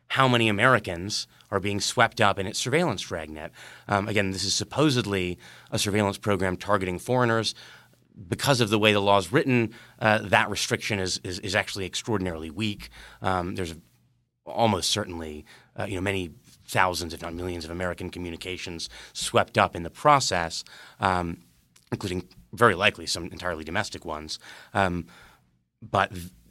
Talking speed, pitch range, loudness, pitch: 150 wpm, 90-110 Hz, -26 LUFS, 95 Hz